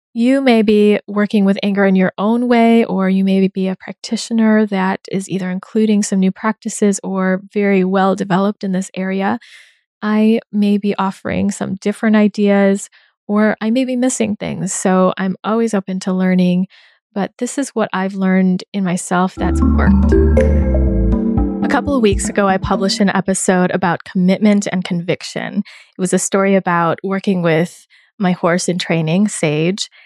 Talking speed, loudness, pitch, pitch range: 170 wpm, -15 LUFS, 195 Hz, 185-210 Hz